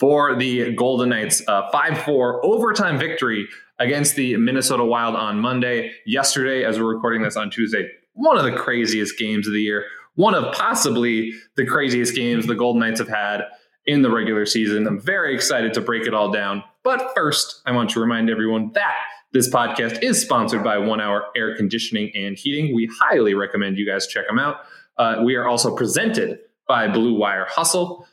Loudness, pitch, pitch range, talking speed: -20 LUFS, 115 Hz, 105-130 Hz, 190 wpm